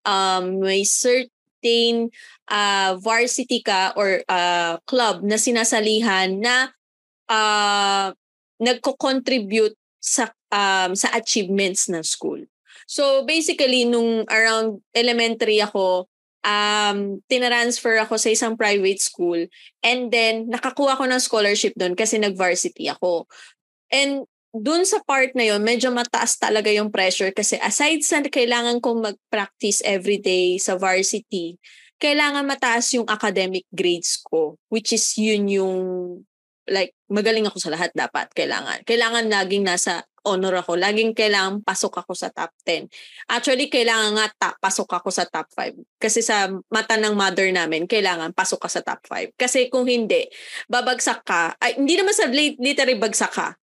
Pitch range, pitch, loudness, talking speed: 195-245 Hz, 220 Hz, -20 LUFS, 140 wpm